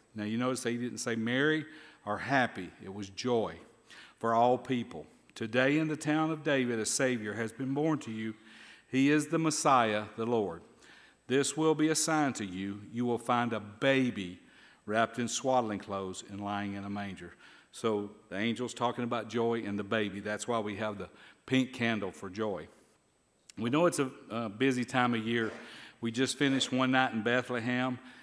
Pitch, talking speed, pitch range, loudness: 120 Hz, 185 wpm, 105-130 Hz, -32 LUFS